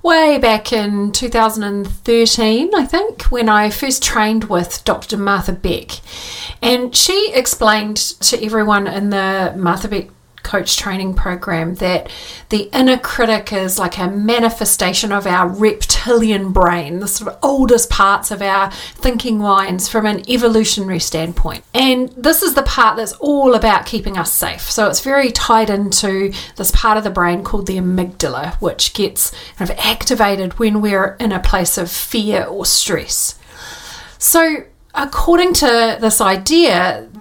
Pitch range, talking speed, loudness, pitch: 190-240 Hz, 150 wpm, -14 LUFS, 215 Hz